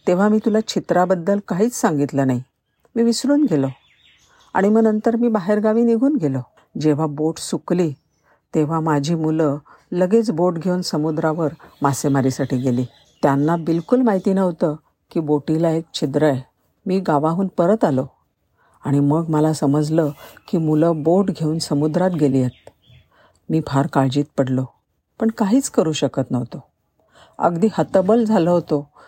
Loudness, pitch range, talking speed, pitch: -19 LUFS, 145-190 Hz, 135 wpm, 160 Hz